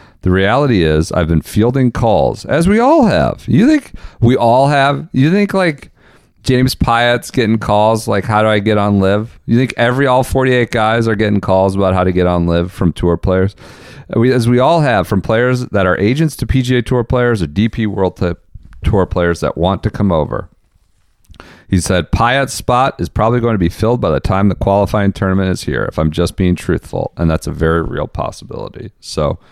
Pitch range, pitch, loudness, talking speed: 90-125 Hz, 105 Hz, -13 LUFS, 210 wpm